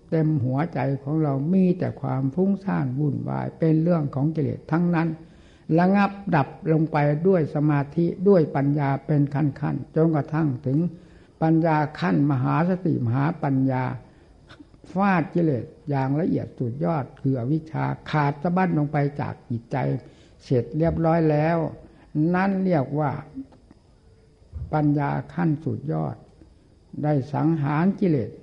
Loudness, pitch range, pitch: -23 LUFS, 140-165 Hz, 150 Hz